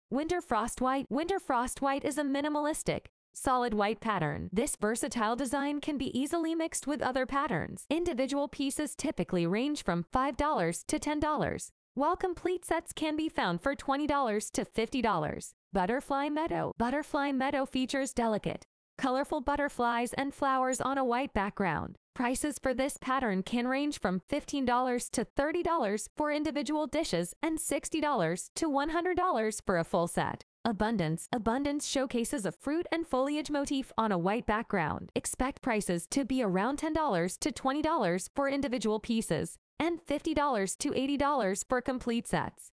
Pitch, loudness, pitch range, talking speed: 270 Hz, -32 LUFS, 225-295 Hz, 145 wpm